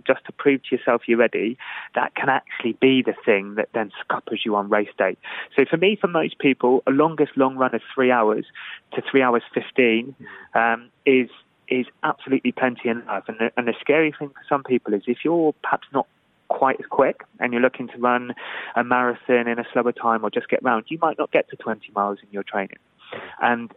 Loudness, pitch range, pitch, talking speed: -22 LUFS, 115-135 Hz, 125 Hz, 215 wpm